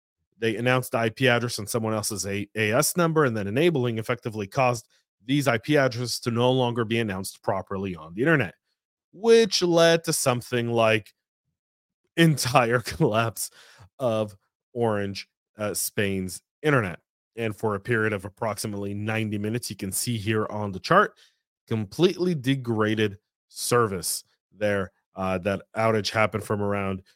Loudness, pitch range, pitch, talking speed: -25 LUFS, 105-125 Hz, 115 Hz, 145 wpm